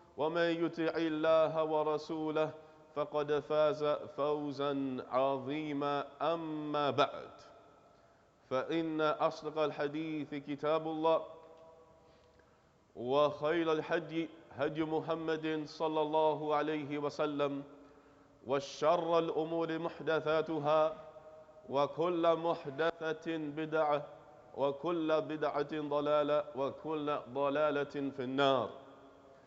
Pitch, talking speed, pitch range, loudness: 155 Hz, 75 wpm, 145-160 Hz, -35 LUFS